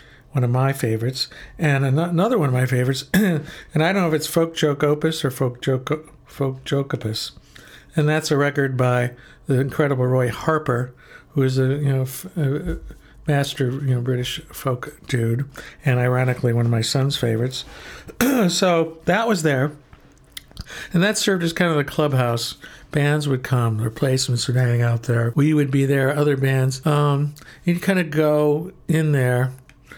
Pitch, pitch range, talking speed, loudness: 140 Hz, 130-155 Hz, 175 wpm, -21 LUFS